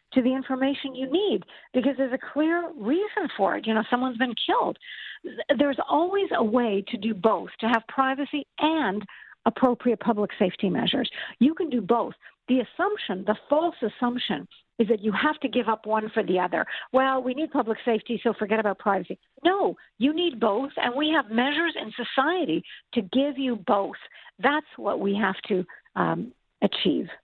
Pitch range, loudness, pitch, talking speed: 220-285 Hz, -26 LUFS, 250 Hz, 180 wpm